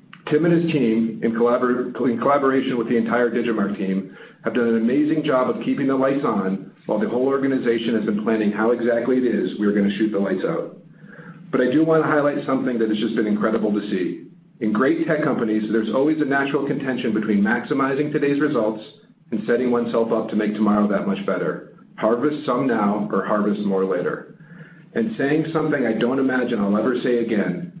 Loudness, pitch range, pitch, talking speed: -21 LUFS, 110-145 Hz, 120 Hz, 205 wpm